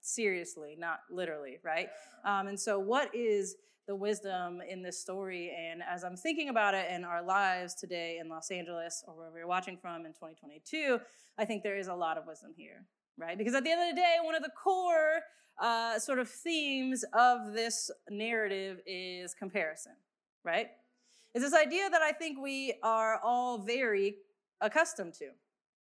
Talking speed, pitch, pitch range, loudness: 180 wpm, 210 Hz, 180-275 Hz, -34 LUFS